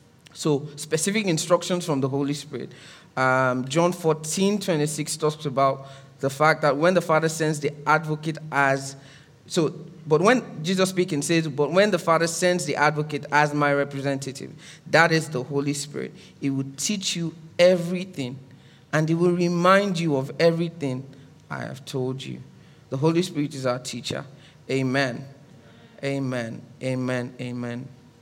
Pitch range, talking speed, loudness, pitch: 135-165 Hz, 150 wpm, -24 LUFS, 150 Hz